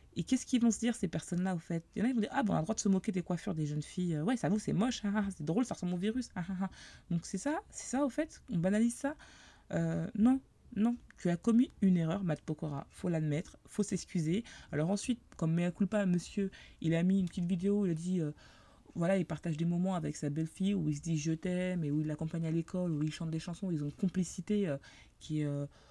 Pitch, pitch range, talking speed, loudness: 180 Hz, 165-210 Hz, 280 wpm, -35 LUFS